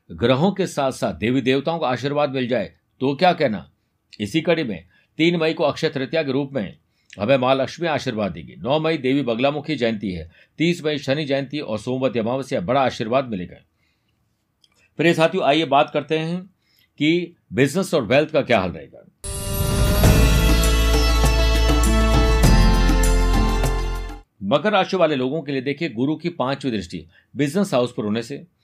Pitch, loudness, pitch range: 135 Hz, -20 LUFS, 110-160 Hz